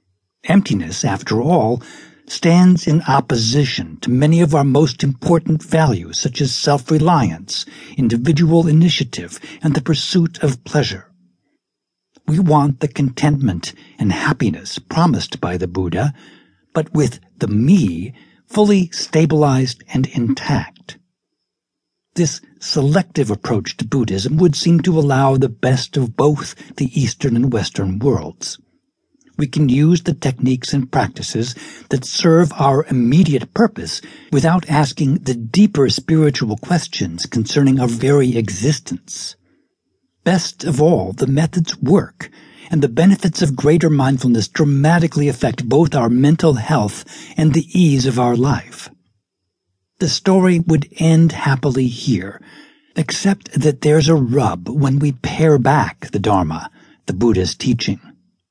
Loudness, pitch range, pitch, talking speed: -16 LUFS, 125-165 Hz, 145 Hz, 130 wpm